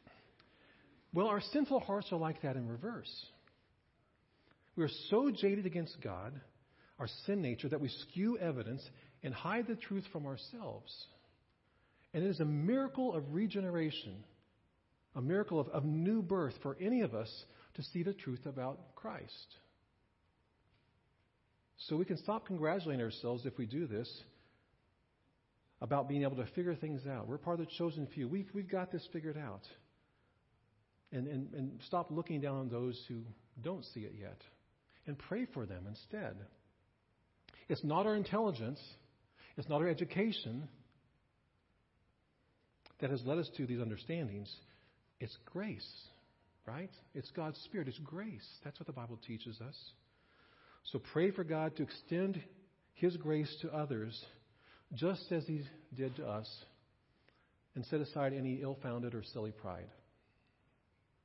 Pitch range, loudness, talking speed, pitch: 115-170 Hz, -40 LUFS, 150 wpm, 135 Hz